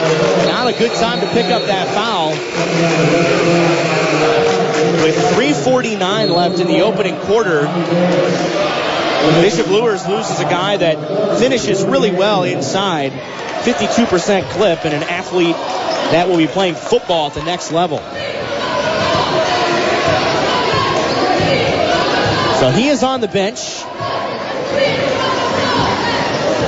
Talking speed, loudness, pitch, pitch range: 105 wpm, -15 LUFS, 180 Hz, 165-210 Hz